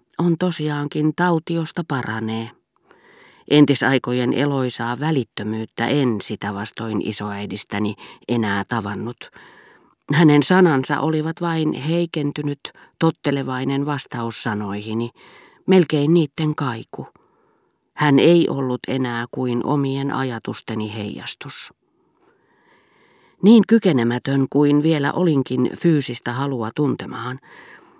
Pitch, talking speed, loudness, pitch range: 135 Hz, 85 wpm, -20 LUFS, 115-155 Hz